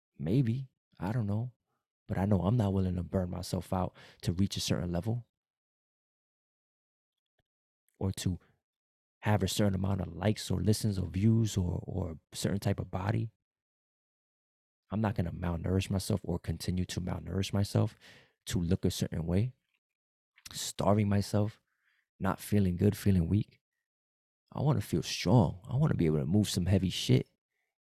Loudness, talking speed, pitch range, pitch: -32 LUFS, 160 wpm, 90-105 Hz, 95 Hz